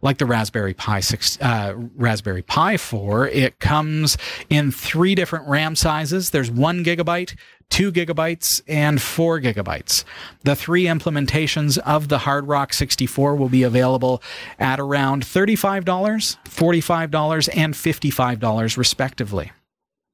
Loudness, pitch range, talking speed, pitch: -19 LUFS, 125-165 Hz, 125 wpm, 145 Hz